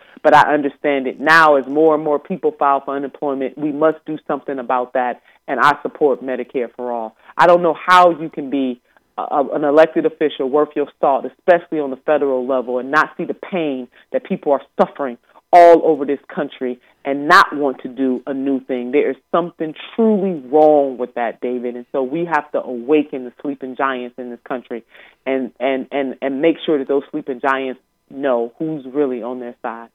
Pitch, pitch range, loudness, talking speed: 140 Hz, 130-155 Hz, -17 LUFS, 200 wpm